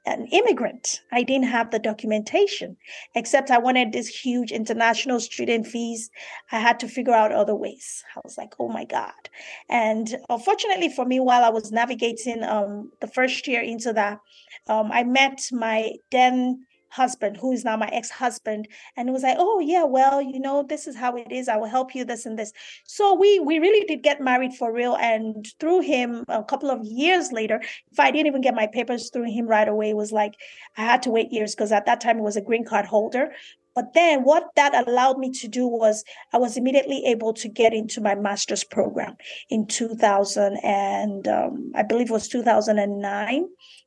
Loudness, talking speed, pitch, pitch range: -22 LUFS, 200 wpm, 240 Hz, 220-265 Hz